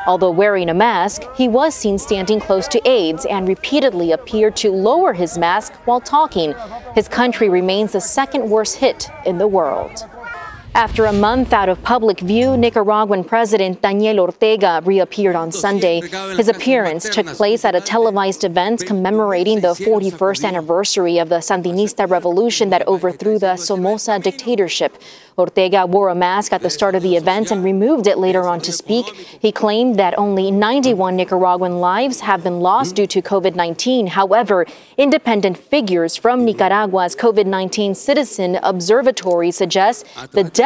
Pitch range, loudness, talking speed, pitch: 185-225 Hz, -16 LUFS, 155 wpm, 200 Hz